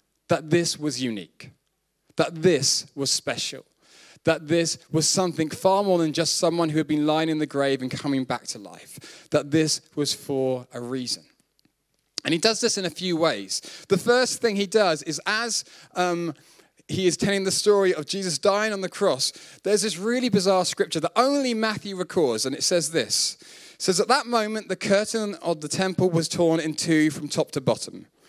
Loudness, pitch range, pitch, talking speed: -24 LUFS, 150-195 Hz, 170 Hz, 195 wpm